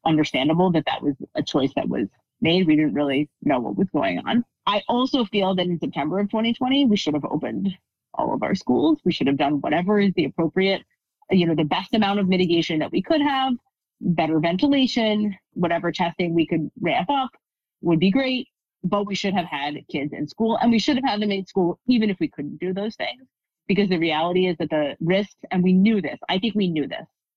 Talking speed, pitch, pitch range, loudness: 225 wpm, 185 Hz, 165-220 Hz, -22 LUFS